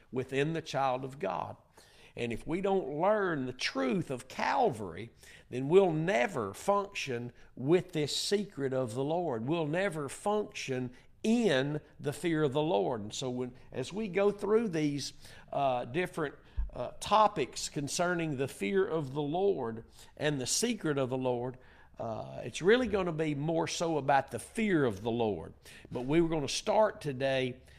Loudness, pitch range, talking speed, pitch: -32 LUFS, 130-185 Hz, 170 wpm, 150 Hz